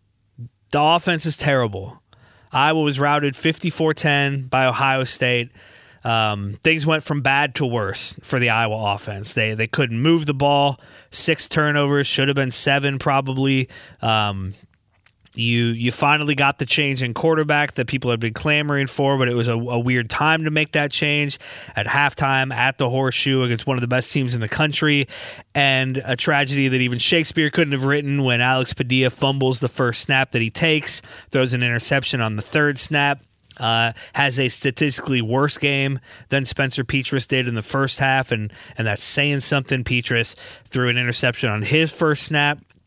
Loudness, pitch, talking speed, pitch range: -19 LUFS, 135 Hz, 180 wpm, 120-145 Hz